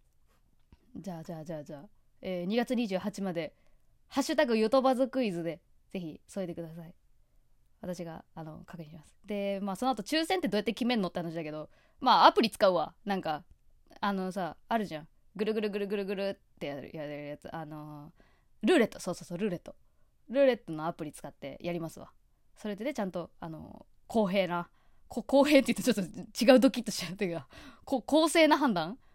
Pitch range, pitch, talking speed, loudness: 165-230 Hz, 190 Hz, 390 characters per minute, -30 LUFS